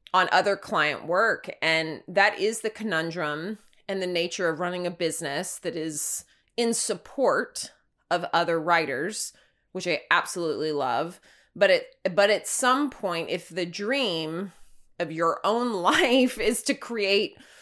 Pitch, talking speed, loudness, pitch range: 185 Hz, 145 wpm, -26 LUFS, 170-220 Hz